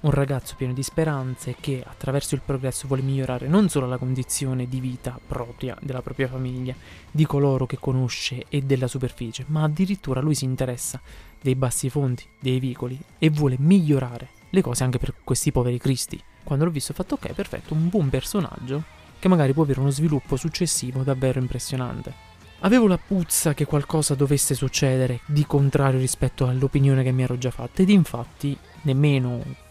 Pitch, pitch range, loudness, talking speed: 135 Hz, 130-150 Hz, -23 LUFS, 175 wpm